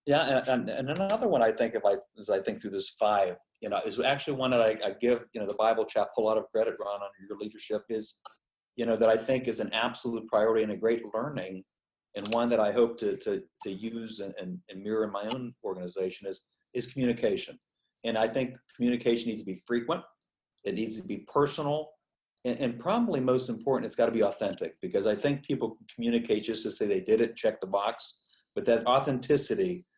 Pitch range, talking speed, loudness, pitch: 110-145 Hz, 225 wpm, -30 LUFS, 120 Hz